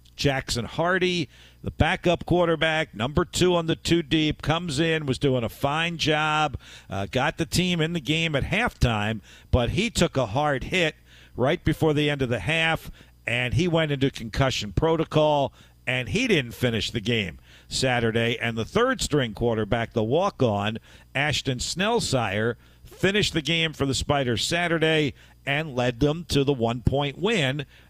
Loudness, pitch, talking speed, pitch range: -24 LUFS, 140 Hz, 170 wpm, 120-160 Hz